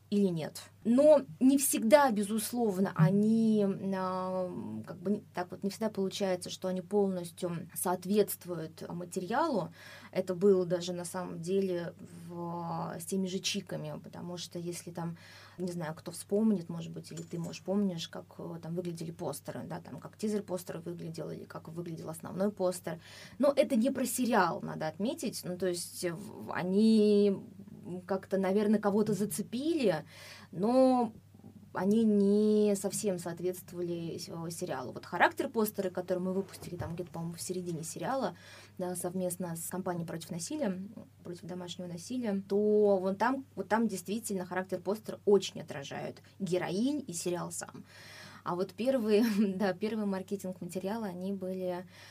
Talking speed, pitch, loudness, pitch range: 145 wpm, 190 Hz, -32 LUFS, 180-210 Hz